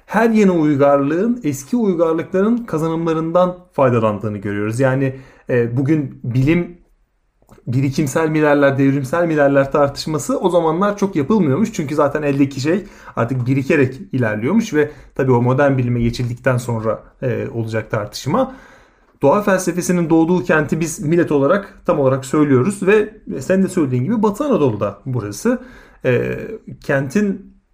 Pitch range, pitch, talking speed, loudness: 135-185 Hz, 150 Hz, 120 wpm, -17 LUFS